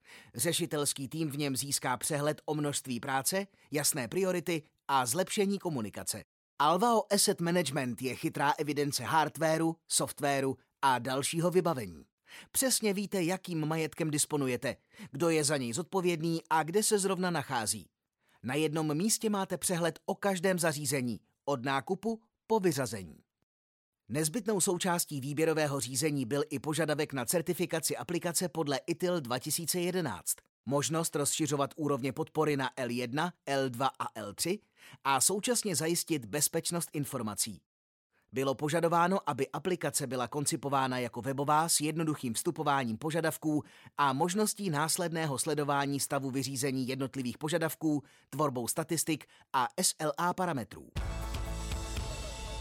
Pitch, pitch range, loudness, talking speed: 150 Hz, 135-170 Hz, -32 LUFS, 120 wpm